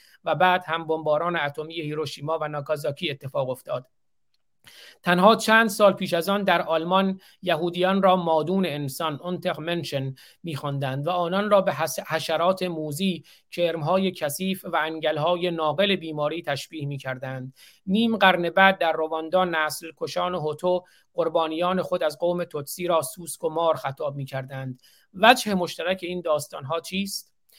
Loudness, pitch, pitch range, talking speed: -24 LUFS, 165 Hz, 150-185 Hz, 135 wpm